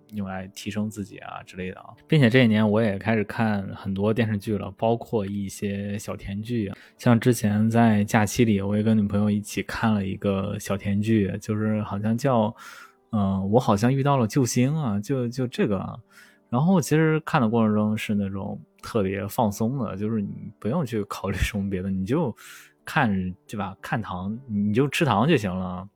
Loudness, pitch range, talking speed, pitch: -24 LUFS, 100-115 Hz, 275 characters per minute, 105 Hz